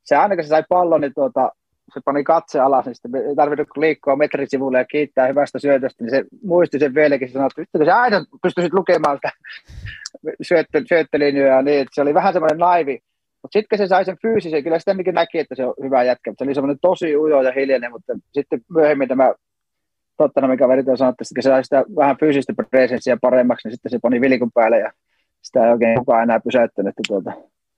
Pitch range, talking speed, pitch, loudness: 130-170 Hz, 205 wpm, 145 Hz, -17 LUFS